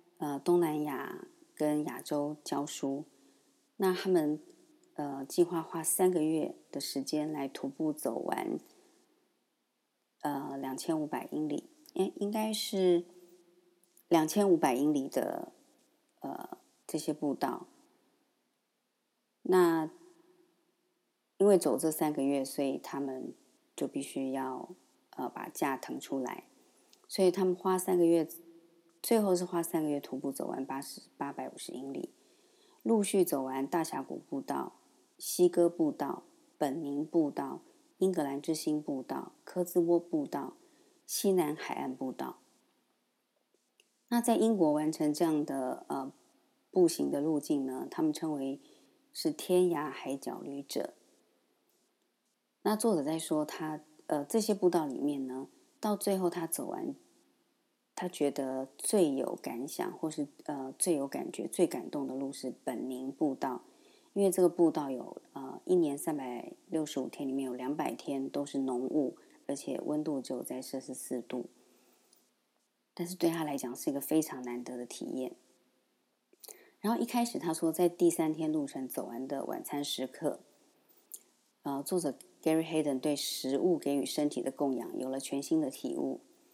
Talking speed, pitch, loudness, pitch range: 215 characters per minute, 170 Hz, -33 LUFS, 145-225 Hz